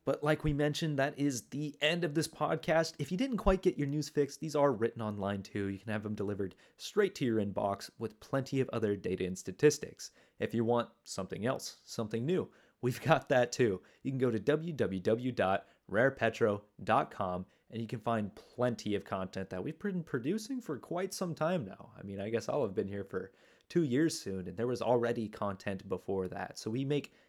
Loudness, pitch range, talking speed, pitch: -34 LUFS, 100-150 Hz, 205 wpm, 125 Hz